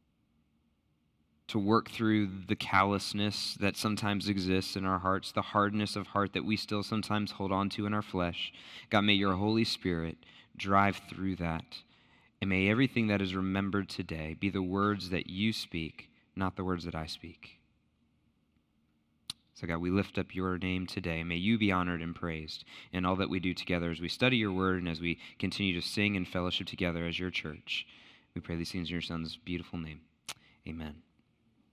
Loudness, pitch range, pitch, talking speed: -32 LUFS, 85-100 Hz, 95 Hz, 185 wpm